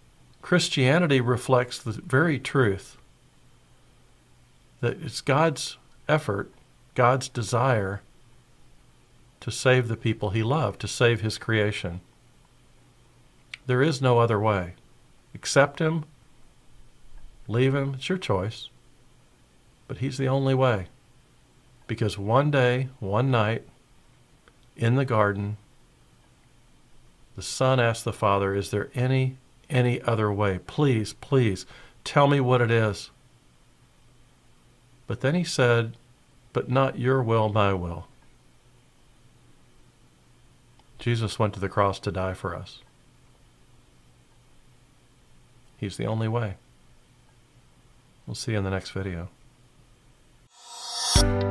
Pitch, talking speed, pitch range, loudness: 120 Hz, 110 wpm, 100-130 Hz, -25 LUFS